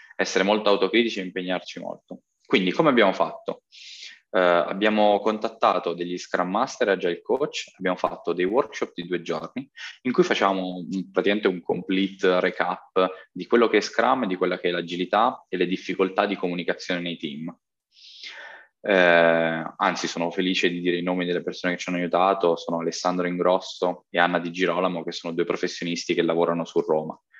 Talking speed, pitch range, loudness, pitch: 175 wpm, 85-95 Hz, -24 LUFS, 90 Hz